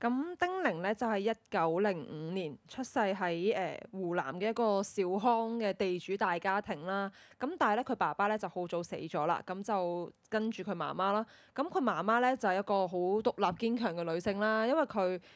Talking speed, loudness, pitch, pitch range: 295 characters per minute, -33 LUFS, 200 Hz, 185-225 Hz